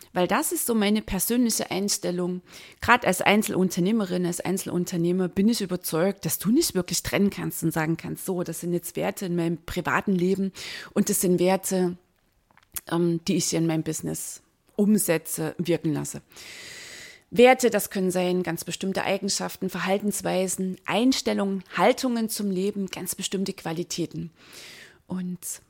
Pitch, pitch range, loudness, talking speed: 185 Hz, 170-200 Hz, -25 LUFS, 145 wpm